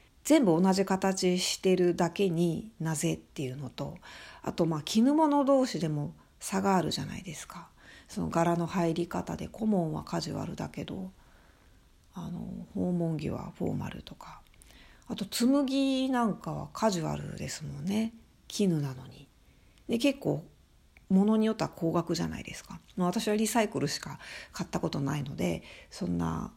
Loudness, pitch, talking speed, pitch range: -30 LUFS, 180 Hz, 300 characters per minute, 155-215 Hz